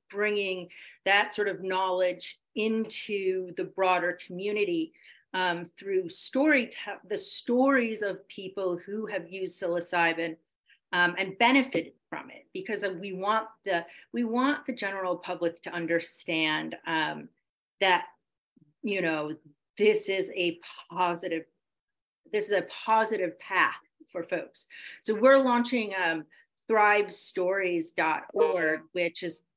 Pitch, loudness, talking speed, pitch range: 190 Hz, -28 LUFS, 120 wpm, 175-220 Hz